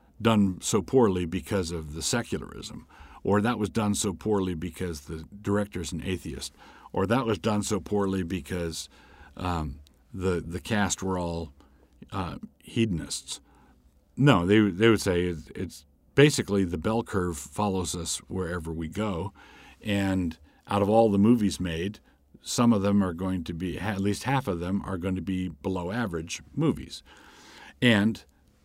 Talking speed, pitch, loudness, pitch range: 155 wpm, 95 Hz, -27 LUFS, 85-105 Hz